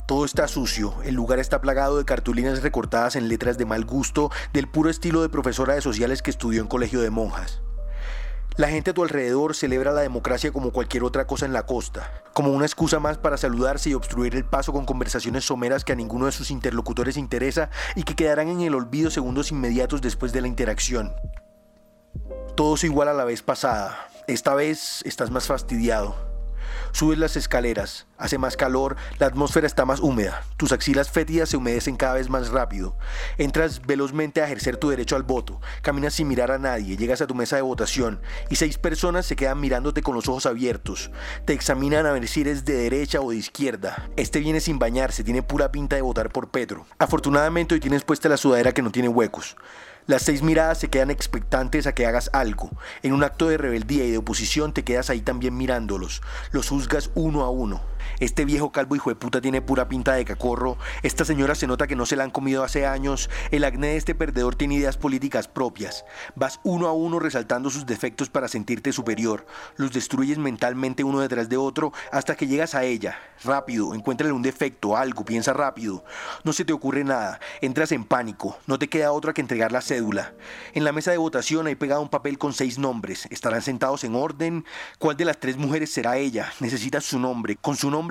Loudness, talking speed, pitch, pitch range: -24 LUFS, 205 wpm, 135 Hz, 125-150 Hz